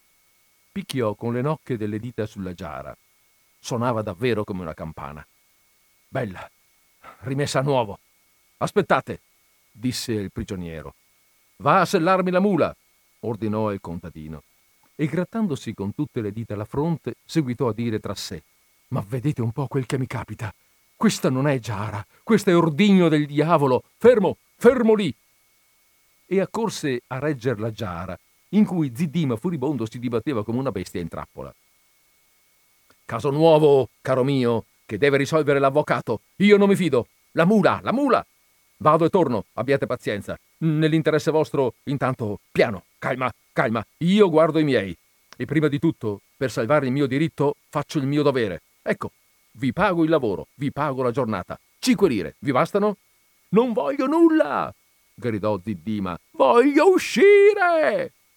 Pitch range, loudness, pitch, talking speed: 110-165 Hz, -22 LUFS, 135 Hz, 145 wpm